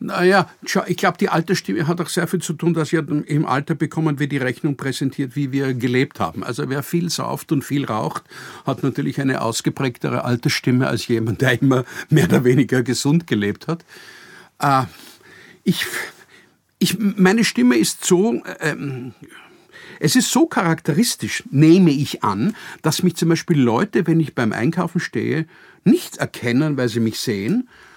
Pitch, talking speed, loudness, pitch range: 155 Hz, 165 wpm, -19 LUFS, 135-180 Hz